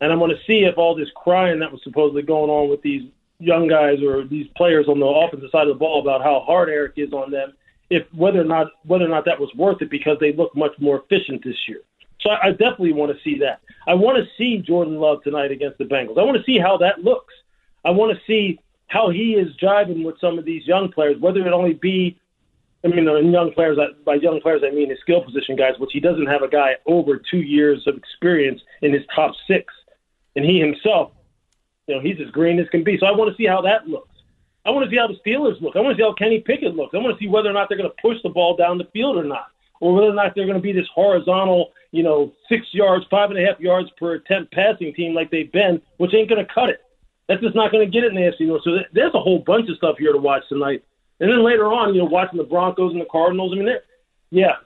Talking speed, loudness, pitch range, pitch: 270 wpm, -18 LUFS, 150-195 Hz, 175 Hz